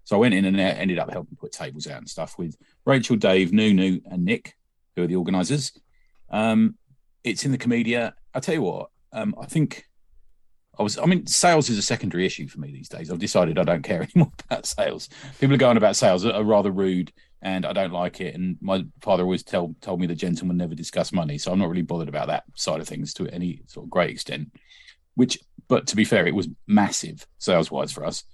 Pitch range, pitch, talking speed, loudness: 90-130 Hz, 95 Hz, 235 wpm, -23 LUFS